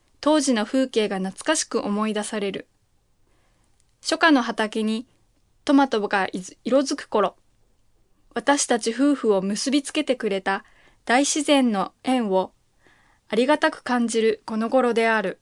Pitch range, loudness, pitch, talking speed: 215-280 Hz, -22 LUFS, 235 Hz, 245 characters per minute